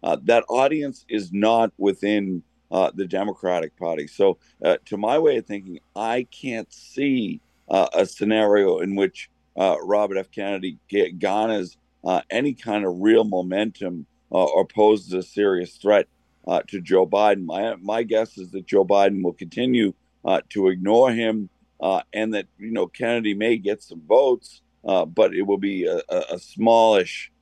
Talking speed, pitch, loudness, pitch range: 170 wpm, 105 Hz, -22 LUFS, 95-115 Hz